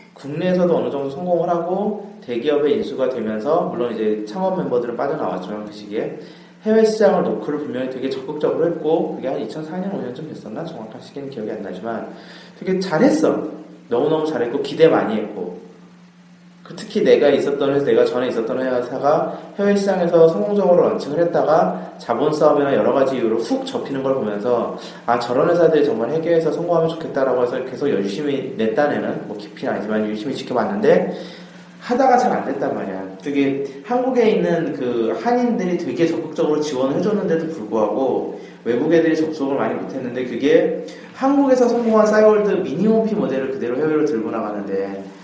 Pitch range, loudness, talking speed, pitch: 135-190 Hz, -19 LUFS, 395 characters per minute, 165 Hz